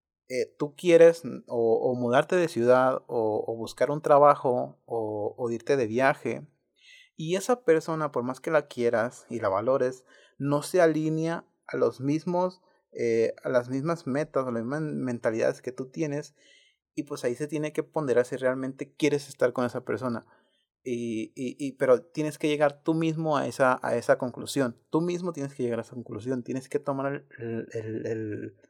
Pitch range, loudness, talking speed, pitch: 125-155 Hz, -27 LUFS, 185 wpm, 140 Hz